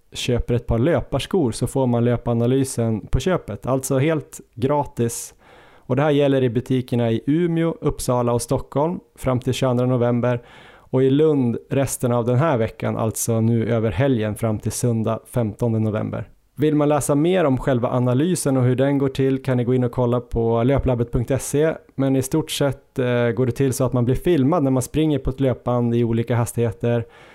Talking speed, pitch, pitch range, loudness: 190 wpm, 125 Hz, 120-140 Hz, -21 LUFS